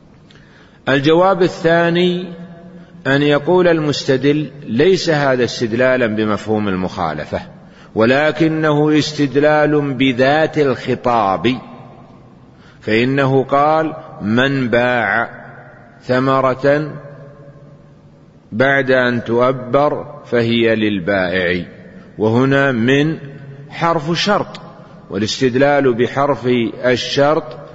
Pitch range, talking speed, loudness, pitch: 120-150 Hz, 65 wpm, -15 LUFS, 140 Hz